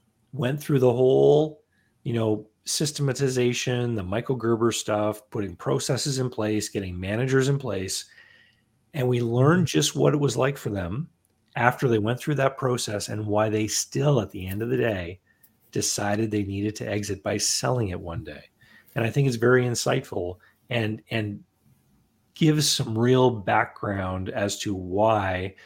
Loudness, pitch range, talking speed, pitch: -25 LUFS, 105-130 Hz, 165 wpm, 115 Hz